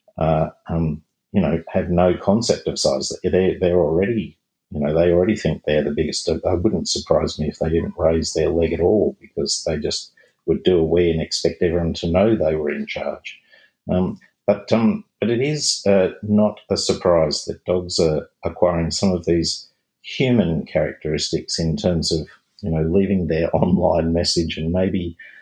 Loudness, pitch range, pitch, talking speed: -20 LUFS, 80-100 Hz, 85 Hz, 180 wpm